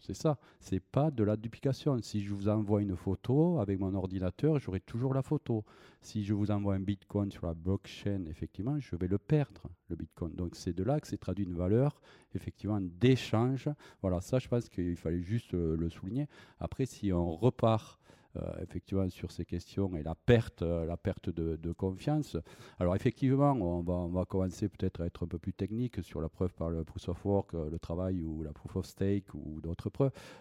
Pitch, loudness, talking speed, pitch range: 95 Hz, -34 LUFS, 210 wpm, 85-115 Hz